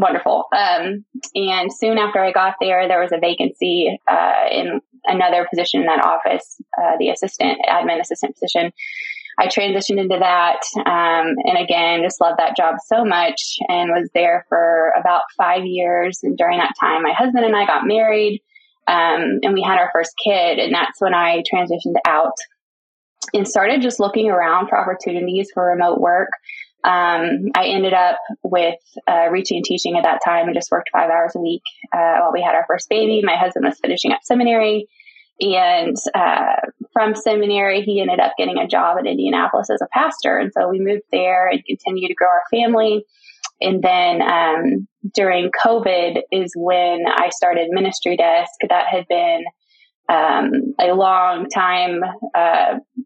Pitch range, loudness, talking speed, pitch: 175-220 Hz, -17 LUFS, 175 wpm, 185 Hz